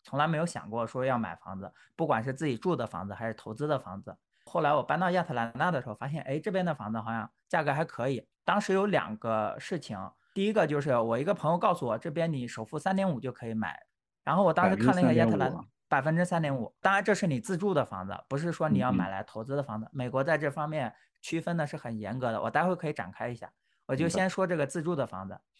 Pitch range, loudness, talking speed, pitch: 115-170 Hz, -30 LUFS, 375 characters per minute, 140 Hz